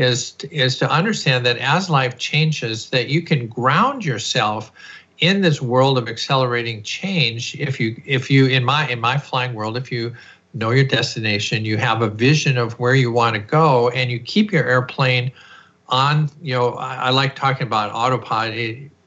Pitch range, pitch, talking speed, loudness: 120-145 Hz, 130 Hz, 180 wpm, -18 LUFS